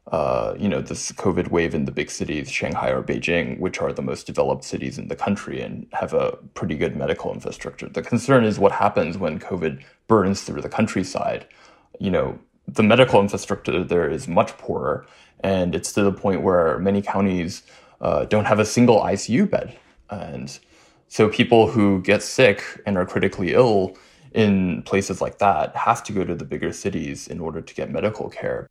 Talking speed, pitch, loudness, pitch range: 190 wpm, 105 Hz, -21 LUFS, 100-115 Hz